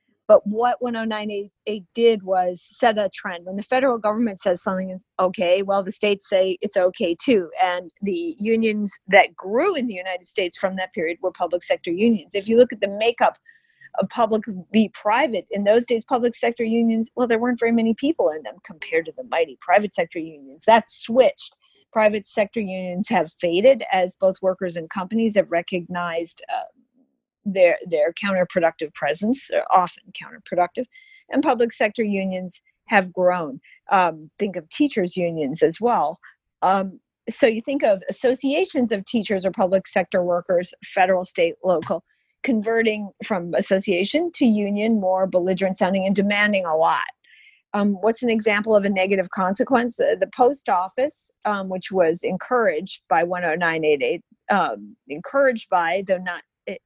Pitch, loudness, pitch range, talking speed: 205 Hz, -21 LUFS, 185-235 Hz, 165 wpm